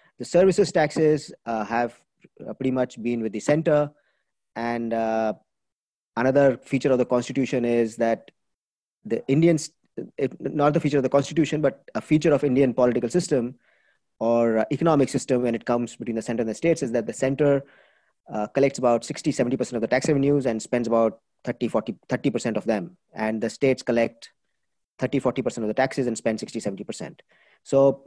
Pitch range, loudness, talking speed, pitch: 115-145 Hz, -24 LUFS, 170 wpm, 130 Hz